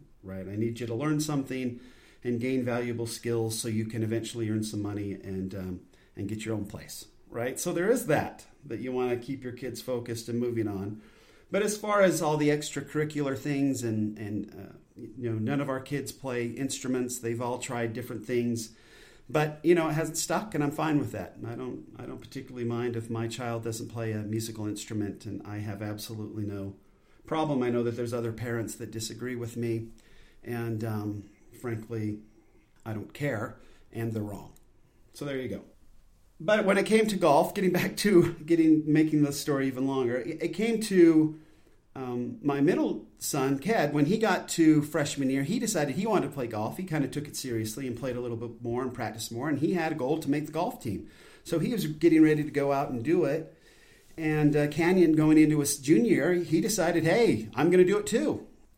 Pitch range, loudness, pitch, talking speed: 115-155 Hz, -29 LUFS, 125 Hz, 210 wpm